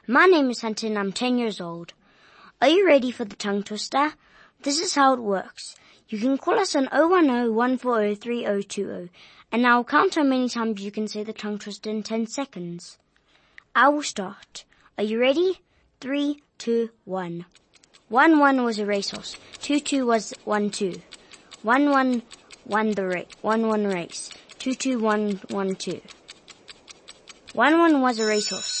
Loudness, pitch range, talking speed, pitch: -23 LUFS, 205-270 Hz, 165 wpm, 230 Hz